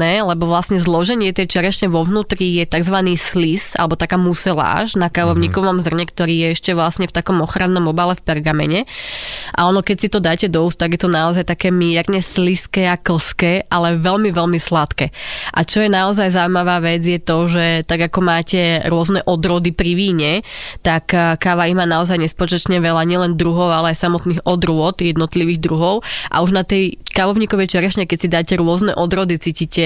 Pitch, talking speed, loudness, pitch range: 175 Hz, 180 wpm, -15 LUFS, 170-185 Hz